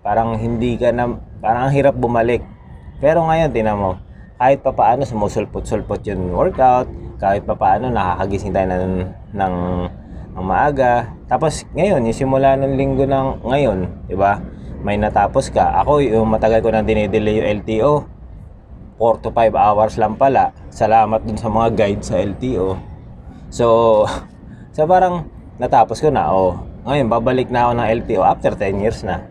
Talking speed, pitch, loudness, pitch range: 160 wpm, 110 Hz, -17 LUFS, 95-120 Hz